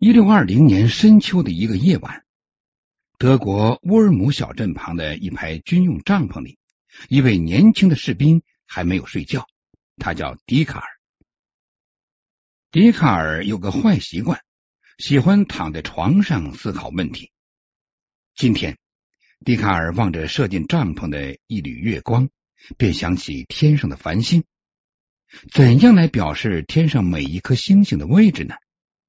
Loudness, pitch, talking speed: -17 LUFS, 135 Hz, 210 characters per minute